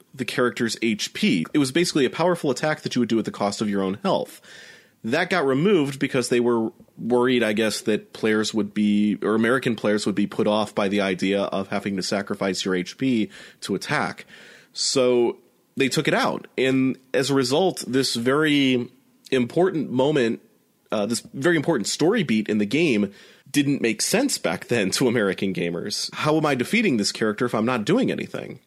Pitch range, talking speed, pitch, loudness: 105-135 Hz, 195 wpm, 120 Hz, -22 LUFS